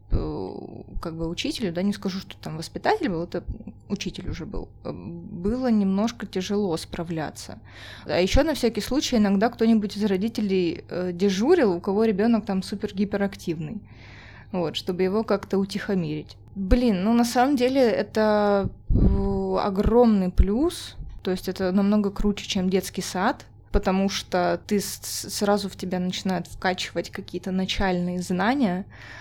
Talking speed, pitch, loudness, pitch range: 135 wpm, 195 Hz, -24 LUFS, 180-210 Hz